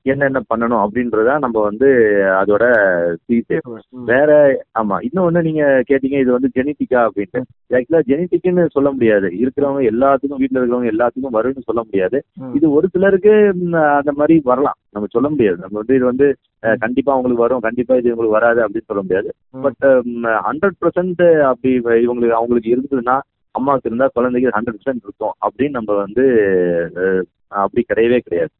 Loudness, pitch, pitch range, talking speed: -15 LUFS, 125 Hz, 115-140 Hz, 145 wpm